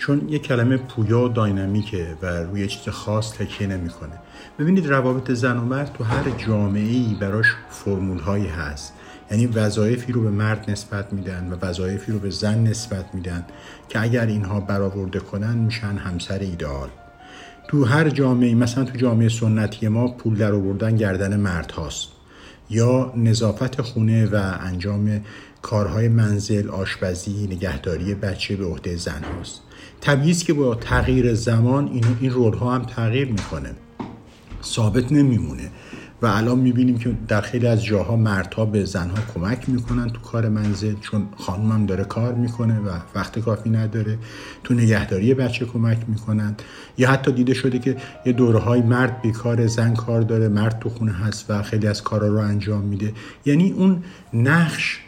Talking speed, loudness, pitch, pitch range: 160 wpm, -21 LUFS, 110 Hz, 100-120 Hz